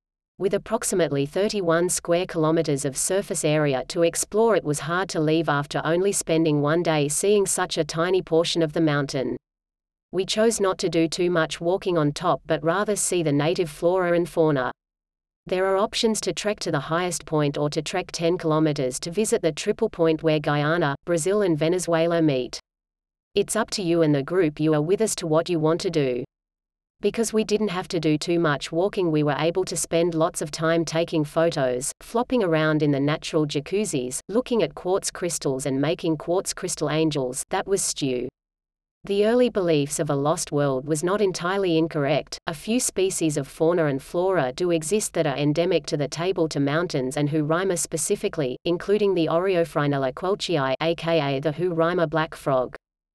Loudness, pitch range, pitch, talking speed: -23 LUFS, 150-185 Hz, 165 Hz, 185 wpm